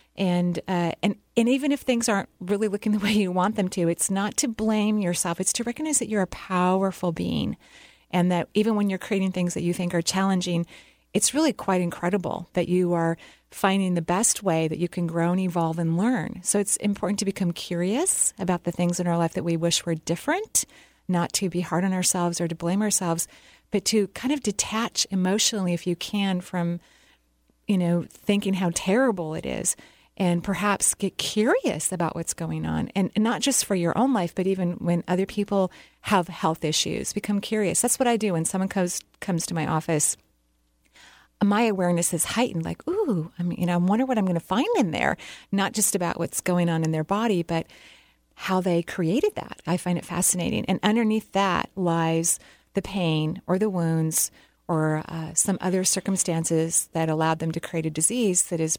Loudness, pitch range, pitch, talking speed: -24 LUFS, 170-205 Hz, 185 Hz, 205 wpm